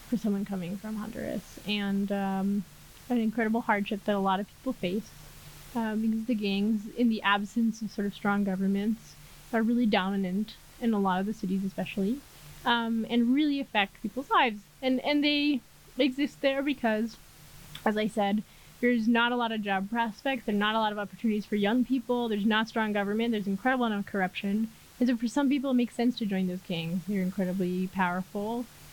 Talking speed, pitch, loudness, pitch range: 195 wpm, 215 Hz, -29 LUFS, 200-235 Hz